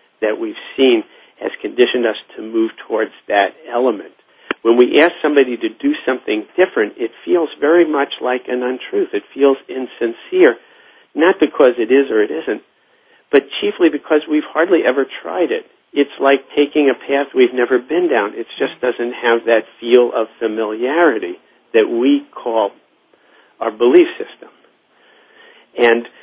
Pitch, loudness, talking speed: 165 Hz, -16 LUFS, 155 wpm